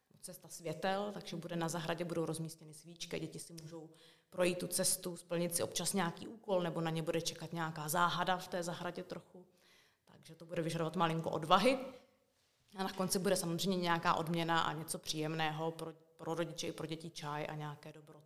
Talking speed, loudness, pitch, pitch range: 185 wpm, -37 LUFS, 170 Hz, 160-180 Hz